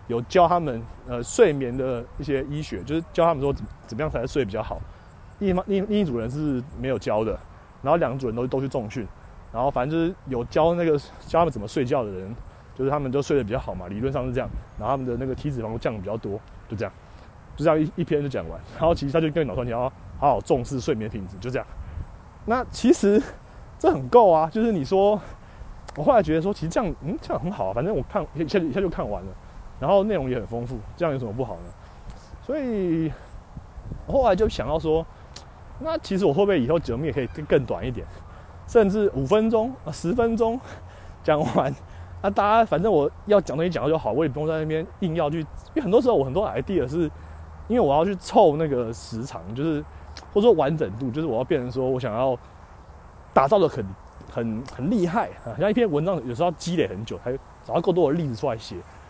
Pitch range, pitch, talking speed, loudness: 105-165 Hz, 130 Hz, 330 characters per minute, -24 LUFS